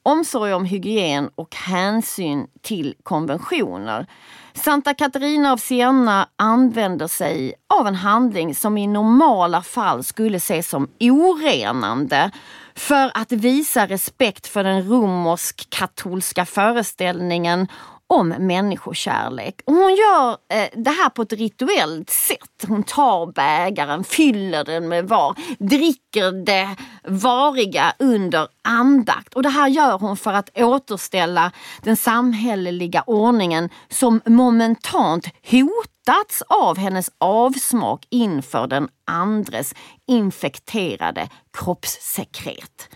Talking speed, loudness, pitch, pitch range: 110 wpm, -19 LUFS, 215 Hz, 180-255 Hz